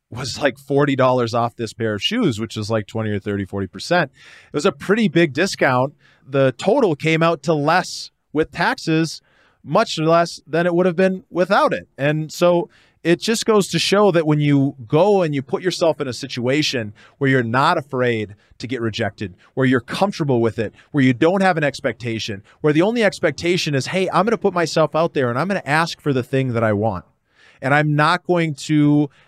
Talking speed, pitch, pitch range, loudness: 210 wpm, 145 Hz, 125-170 Hz, -19 LUFS